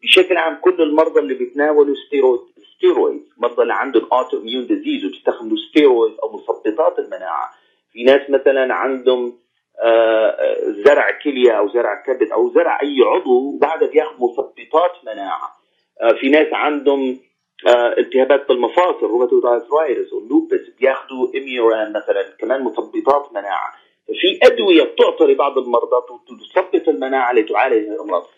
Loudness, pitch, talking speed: -16 LUFS, 365 Hz, 125 wpm